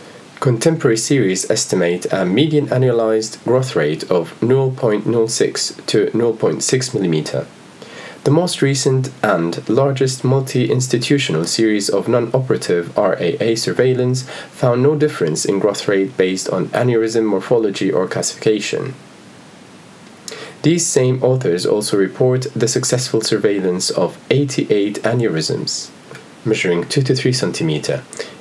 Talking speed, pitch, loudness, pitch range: 115 wpm, 125 Hz, -17 LUFS, 110-135 Hz